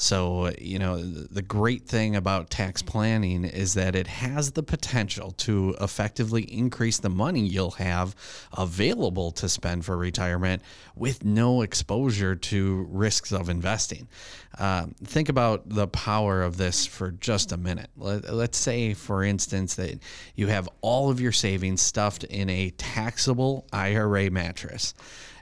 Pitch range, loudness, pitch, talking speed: 95-110 Hz, -26 LUFS, 100 Hz, 145 wpm